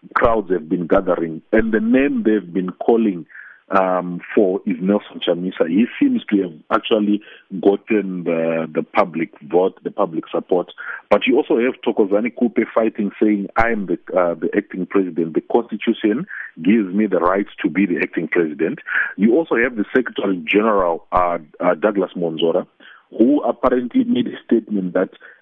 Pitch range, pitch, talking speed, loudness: 90-115 Hz, 105 Hz, 165 wpm, -19 LUFS